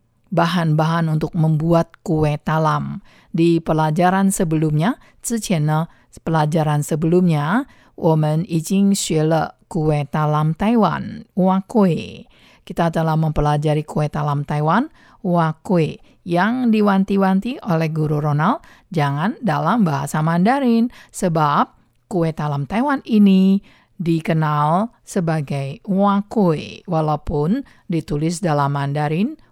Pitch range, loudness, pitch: 155-195 Hz, -19 LUFS, 165 Hz